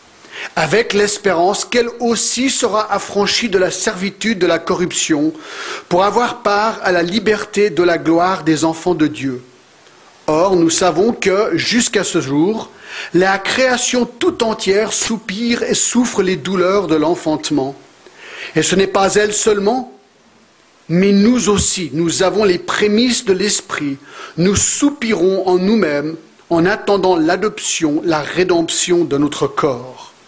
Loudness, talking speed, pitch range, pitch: -14 LUFS, 140 wpm, 175-230 Hz, 200 Hz